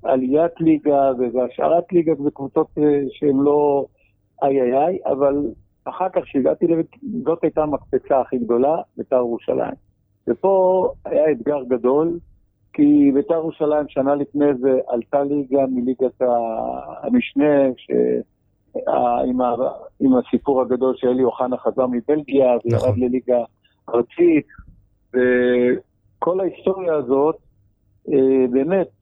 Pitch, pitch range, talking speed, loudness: 135 Hz, 125-150 Hz, 100 wpm, -19 LUFS